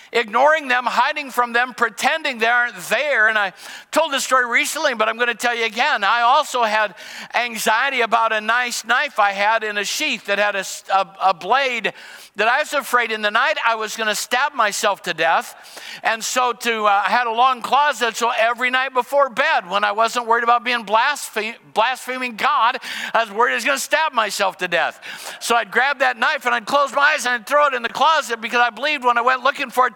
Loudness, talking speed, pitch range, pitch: -18 LUFS, 230 wpm, 220-265 Hz, 240 Hz